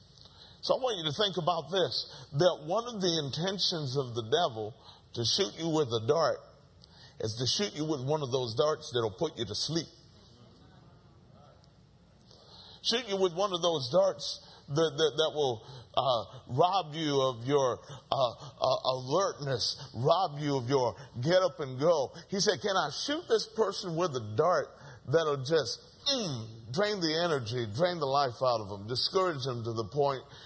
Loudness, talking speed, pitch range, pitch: -30 LUFS, 175 wpm, 130-180 Hz, 150 Hz